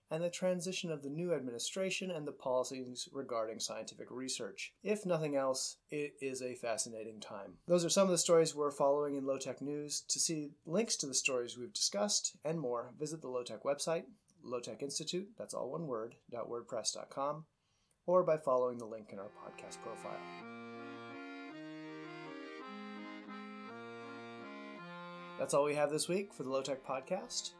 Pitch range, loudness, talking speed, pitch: 115-170 Hz, -37 LUFS, 165 wpm, 140 Hz